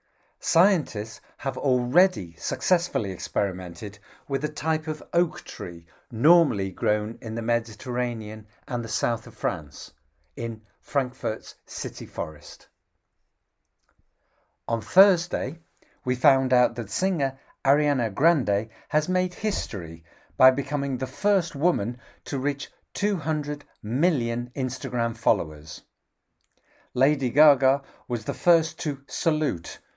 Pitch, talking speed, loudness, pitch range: 130 Hz, 110 wpm, -25 LUFS, 110-150 Hz